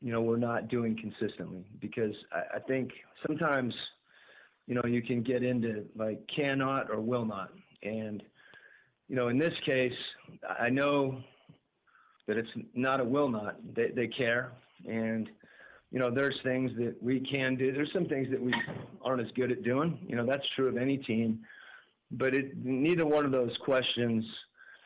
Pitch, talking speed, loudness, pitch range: 125 Hz, 175 wpm, -32 LUFS, 115-135 Hz